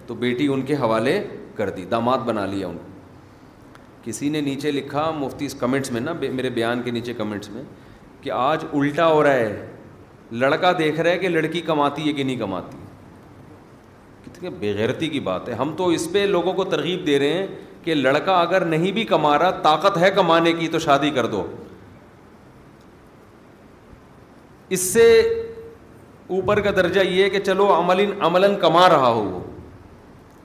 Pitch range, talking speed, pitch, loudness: 125-185 Hz, 170 wpm, 150 Hz, -20 LUFS